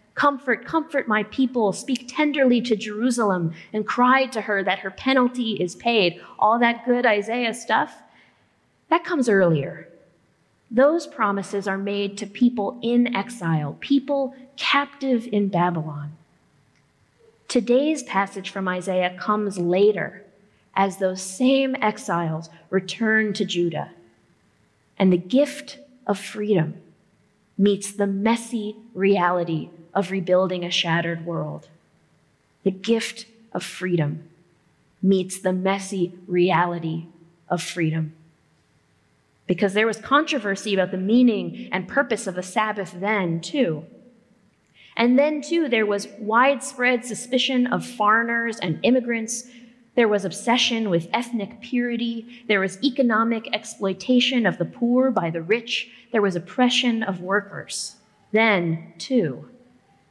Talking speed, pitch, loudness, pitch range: 120 wpm, 210 Hz, -22 LUFS, 185-245 Hz